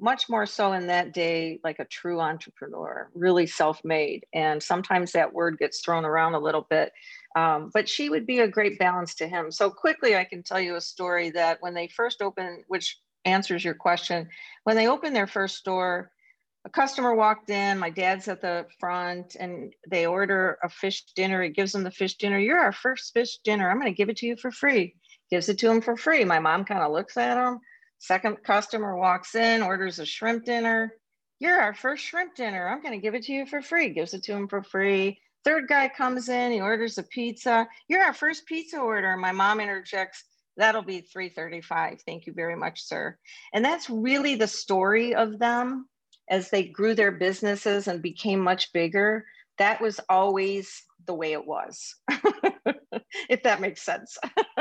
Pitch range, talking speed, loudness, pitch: 180-235 Hz, 200 wpm, -26 LUFS, 200 Hz